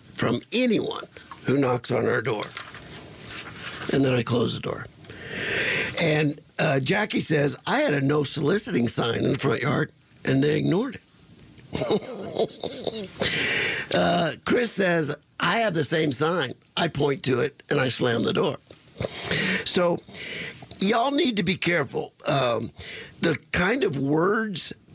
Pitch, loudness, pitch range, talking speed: 155 Hz, -24 LUFS, 145-185 Hz, 140 wpm